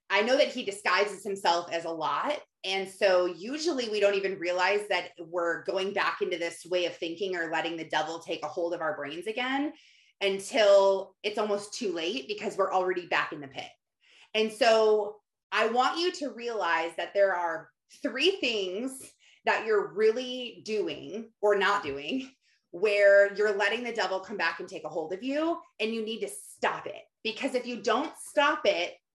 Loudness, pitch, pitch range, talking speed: -28 LUFS, 205 Hz, 180-235 Hz, 190 wpm